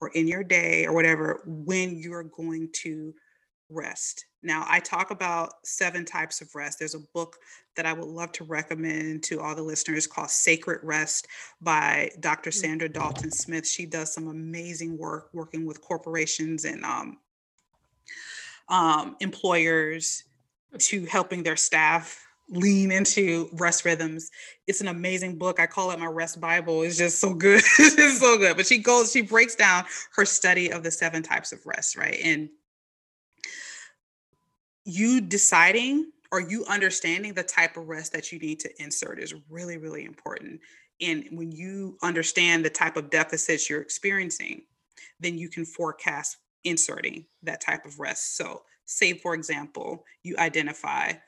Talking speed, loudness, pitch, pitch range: 160 wpm, -24 LUFS, 165 Hz, 160-185 Hz